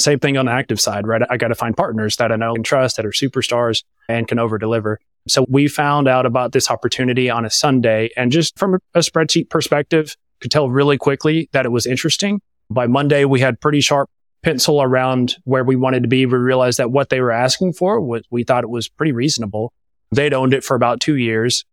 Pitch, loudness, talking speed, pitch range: 130 Hz, -16 LUFS, 230 wpm, 120-145 Hz